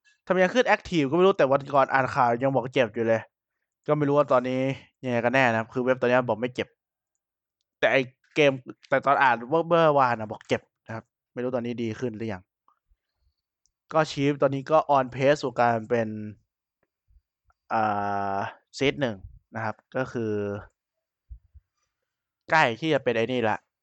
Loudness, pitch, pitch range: -25 LUFS, 125 Hz, 110-140 Hz